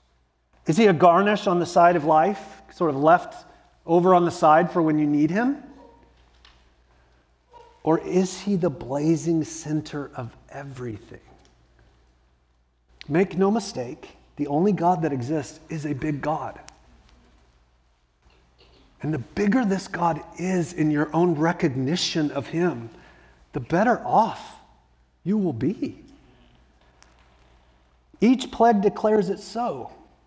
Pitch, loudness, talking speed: 155 Hz, -22 LUFS, 125 wpm